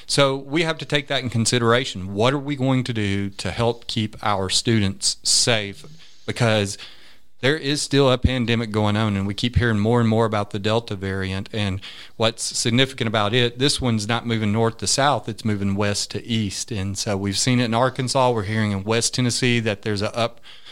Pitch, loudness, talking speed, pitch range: 115 Hz, -21 LUFS, 210 wpm, 105-125 Hz